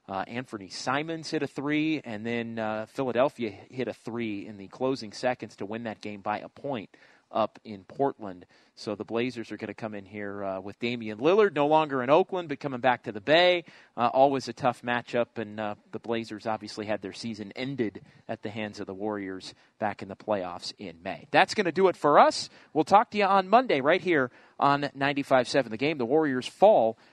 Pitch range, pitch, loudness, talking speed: 105-140 Hz, 120 Hz, -27 LUFS, 220 wpm